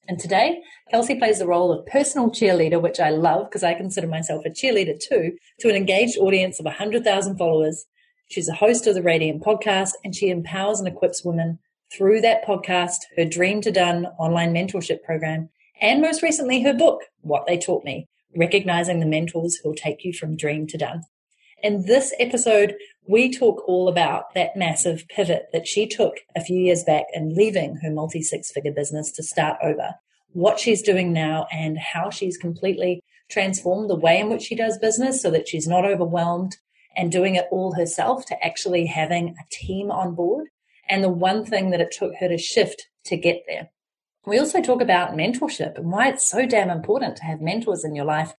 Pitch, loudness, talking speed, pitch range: 185 Hz, -21 LUFS, 195 wpm, 170-215 Hz